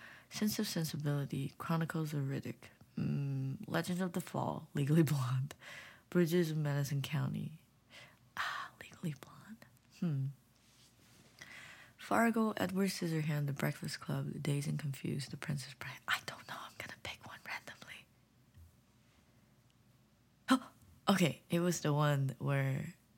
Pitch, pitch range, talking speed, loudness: 145 Hz, 125-170 Hz, 125 wpm, -37 LUFS